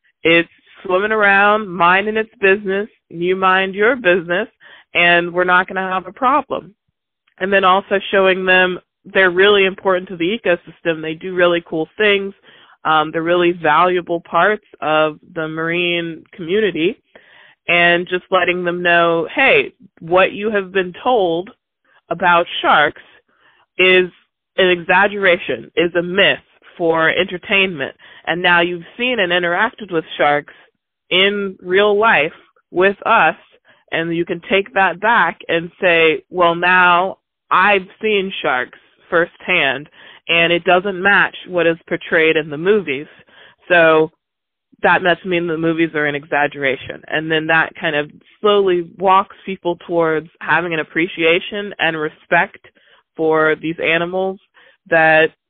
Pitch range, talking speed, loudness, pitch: 165-195 Hz, 140 wpm, -15 LUFS, 180 Hz